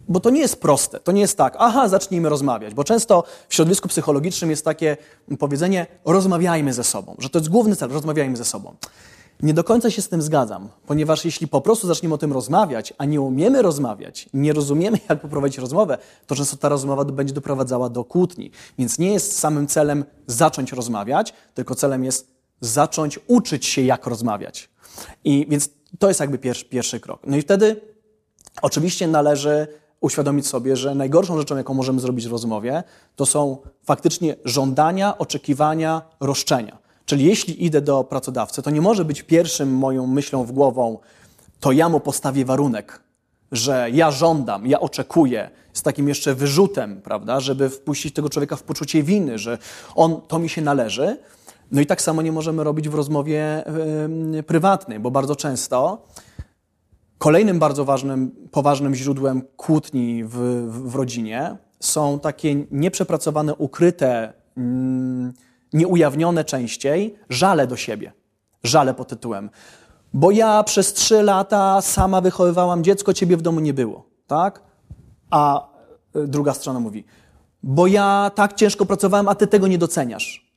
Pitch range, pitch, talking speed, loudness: 135-170 Hz, 150 Hz, 160 wpm, -19 LUFS